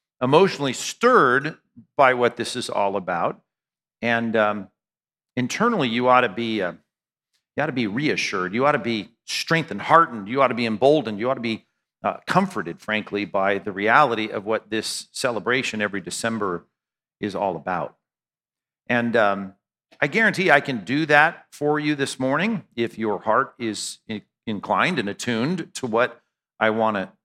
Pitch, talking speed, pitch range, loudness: 115 Hz, 165 wpm, 105-135 Hz, -22 LUFS